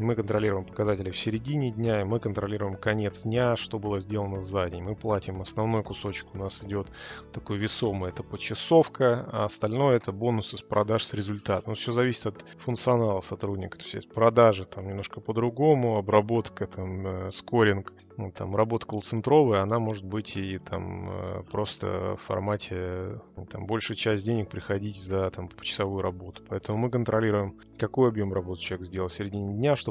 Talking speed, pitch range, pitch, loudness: 170 wpm, 95-115 Hz, 105 Hz, -28 LUFS